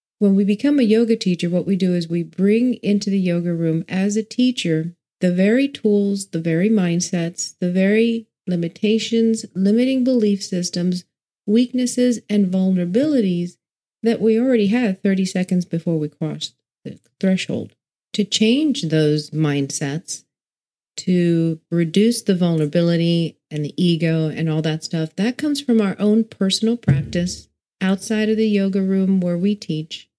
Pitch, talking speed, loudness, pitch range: 190 Hz, 150 wpm, -19 LUFS, 170-220 Hz